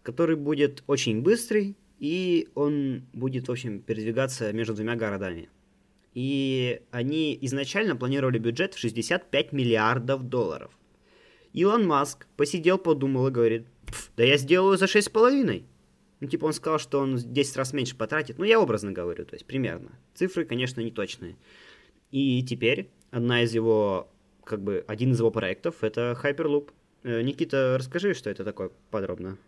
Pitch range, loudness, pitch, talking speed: 115-155 Hz, -26 LUFS, 130 Hz, 150 wpm